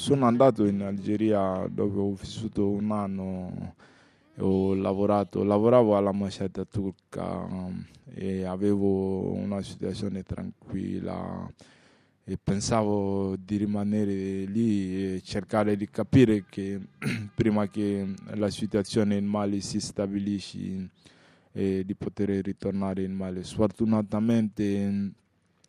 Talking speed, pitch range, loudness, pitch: 105 wpm, 95-105 Hz, -28 LUFS, 100 Hz